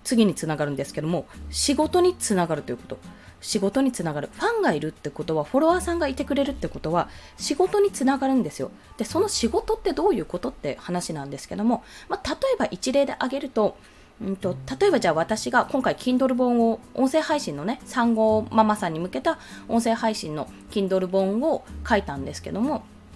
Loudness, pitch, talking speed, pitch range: -24 LUFS, 225 Hz, 425 characters per minute, 175-280 Hz